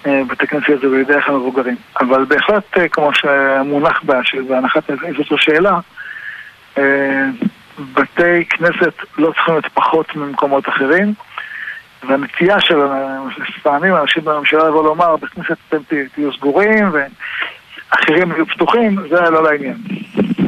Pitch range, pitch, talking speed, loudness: 140-175 Hz, 150 Hz, 115 wpm, -14 LUFS